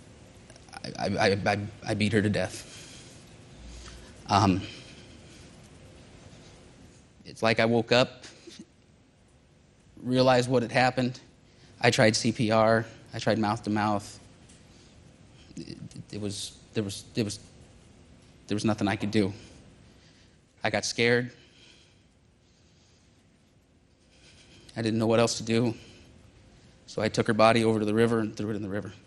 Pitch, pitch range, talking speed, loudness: 110 Hz, 100-115 Hz, 120 wpm, -26 LUFS